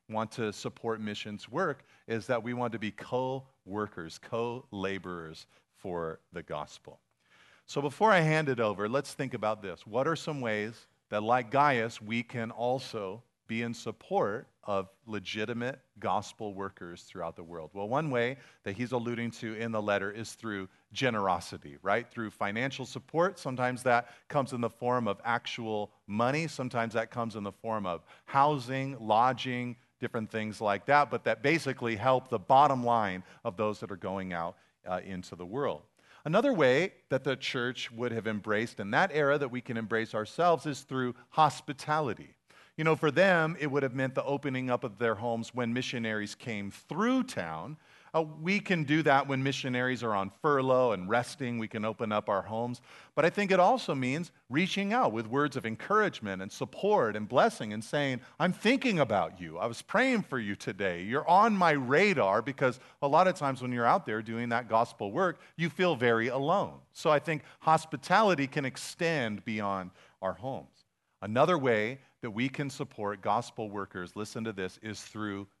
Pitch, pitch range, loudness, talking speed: 120 Hz, 105-140 Hz, -31 LUFS, 185 wpm